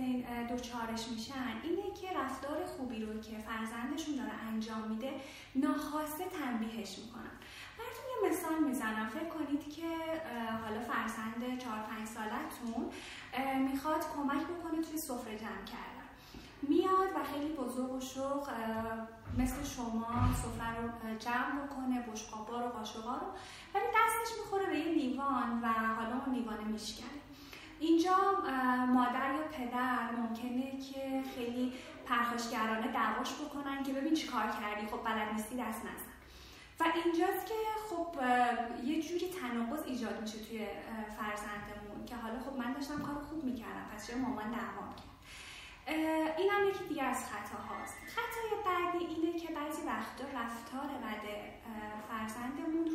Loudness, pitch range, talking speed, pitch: -37 LUFS, 230-310 Hz, 135 wpm, 255 Hz